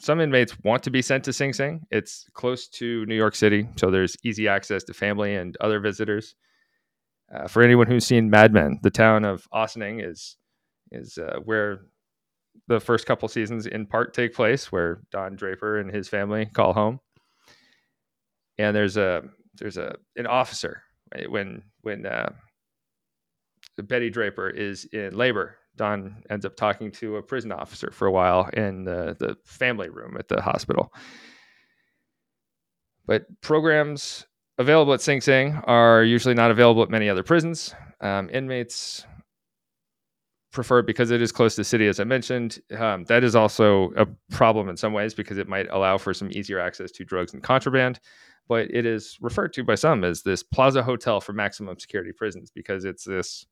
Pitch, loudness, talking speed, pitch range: 110 Hz, -23 LUFS, 175 wpm, 100-120 Hz